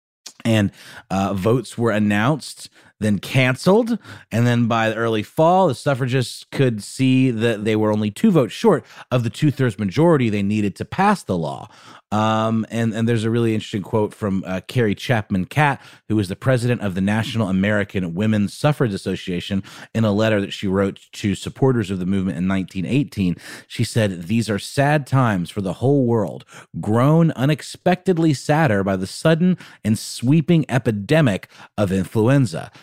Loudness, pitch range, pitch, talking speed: -20 LUFS, 100-135 Hz, 115 Hz, 170 wpm